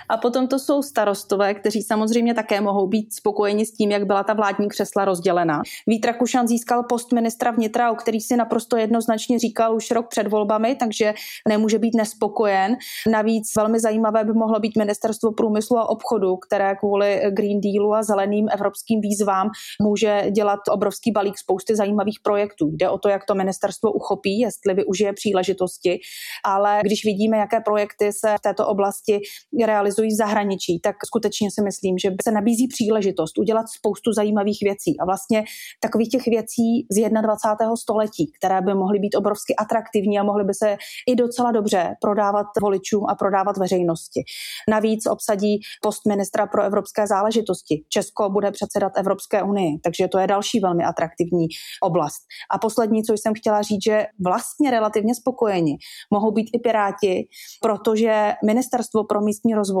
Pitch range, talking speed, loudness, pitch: 200-225 Hz, 165 wpm, -21 LUFS, 210 Hz